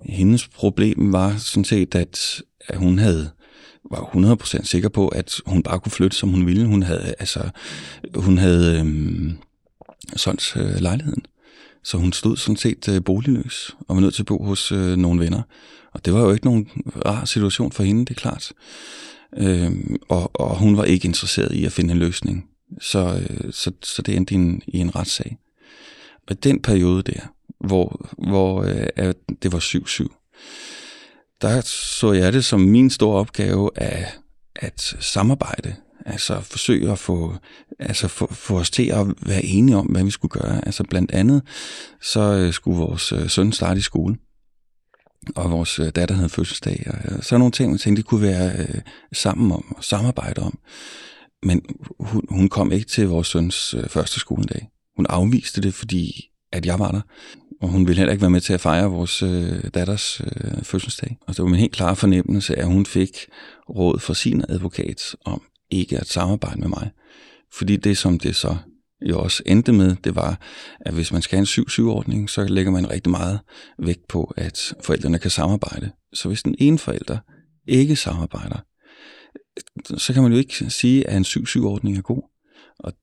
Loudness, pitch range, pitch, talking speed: -20 LUFS, 90-110 Hz, 95 Hz, 180 wpm